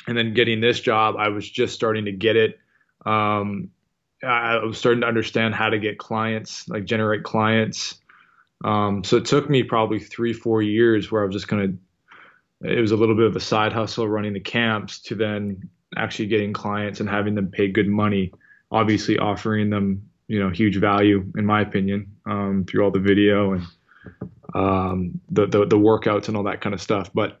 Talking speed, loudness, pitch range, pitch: 195 wpm, -21 LUFS, 100-110 Hz, 105 Hz